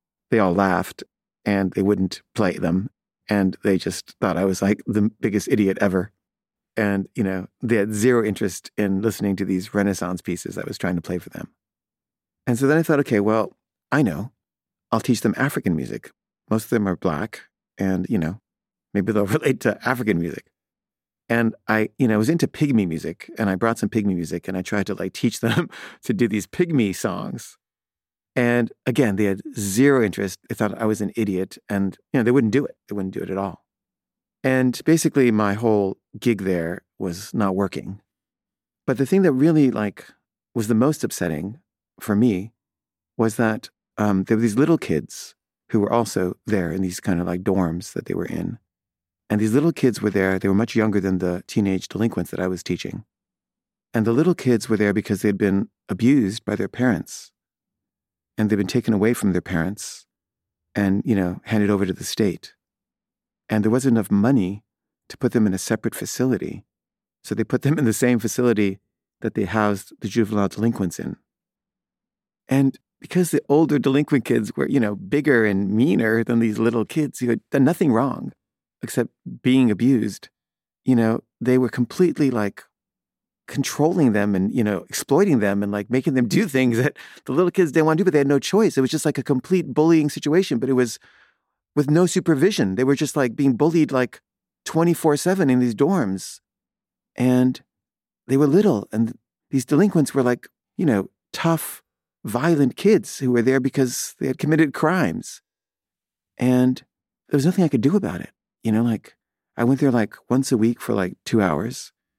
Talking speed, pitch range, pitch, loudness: 195 wpm, 100-135 Hz, 115 Hz, -21 LUFS